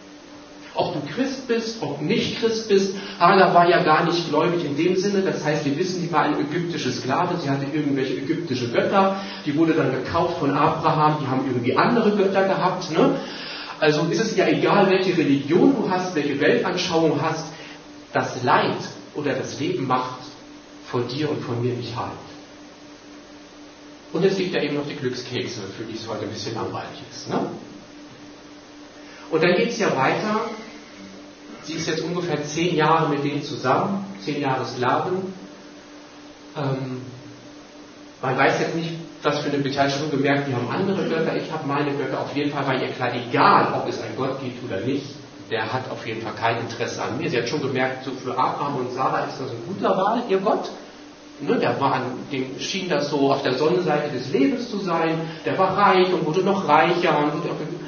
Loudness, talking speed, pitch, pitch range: -22 LUFS, 195 wpm, 150 Hz, 135-180 Hz